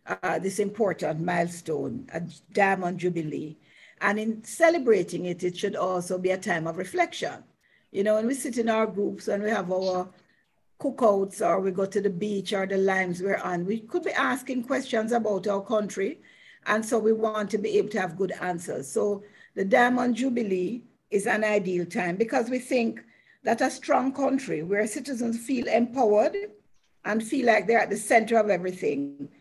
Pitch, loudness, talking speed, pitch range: 210 Hz, -26 LUFS, 185 wpm, 185-240 Hz